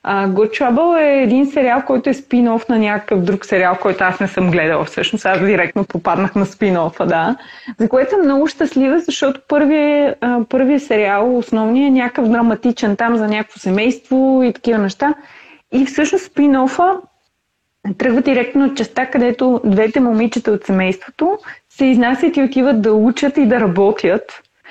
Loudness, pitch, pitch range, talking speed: -15 LUFS, 245 Hz, 210-275 Hz, 165 wpm